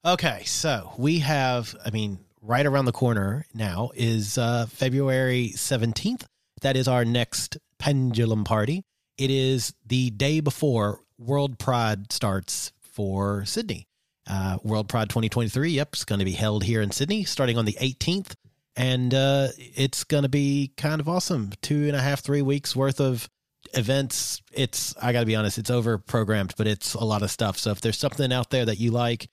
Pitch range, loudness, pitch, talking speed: 110-140 Hz, -25 LUFS, 125 Hz, 180 wpm